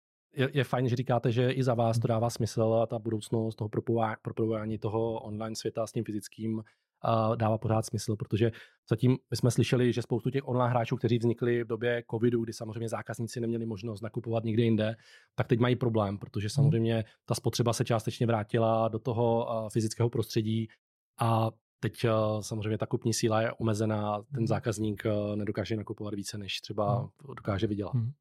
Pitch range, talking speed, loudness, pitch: 110-120 Hz, 170 wpm, -30 LUFS, 115 Hz